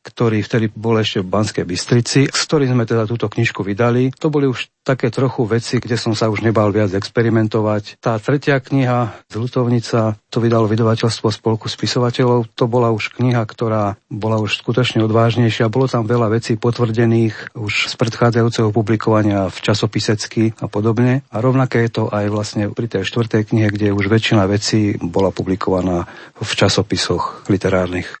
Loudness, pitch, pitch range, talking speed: -17 LUFS, 115 Hz, 105-120 Hz, 165 wpm